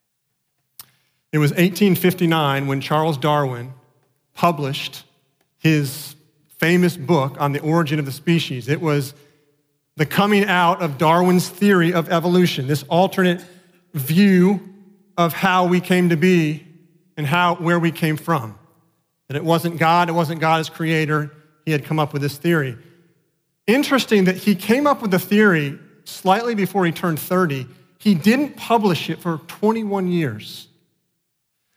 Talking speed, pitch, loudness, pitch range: 145 wpm, 165 Hz, -19 LUFS, 150-180 Hz